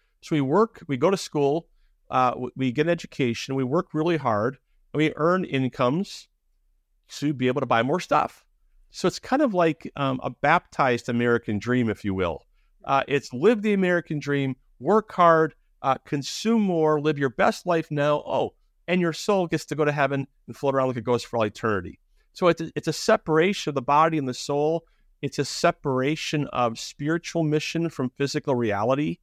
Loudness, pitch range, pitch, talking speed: -24 LUFS, 130-165 Hz, 145 Hz, 195 wpm